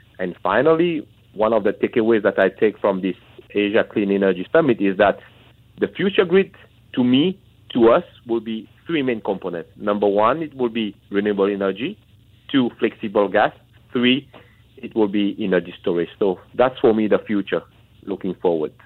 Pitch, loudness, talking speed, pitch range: 110 Hz, -20 LUFS, 170 wpm, 100-125 Hz